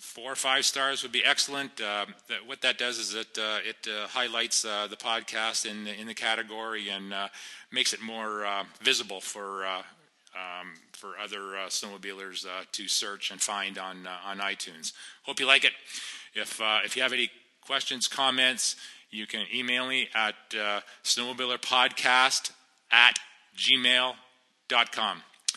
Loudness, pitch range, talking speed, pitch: -27 LUFS, 100-125 Hz, 165 wpm, 110 Hz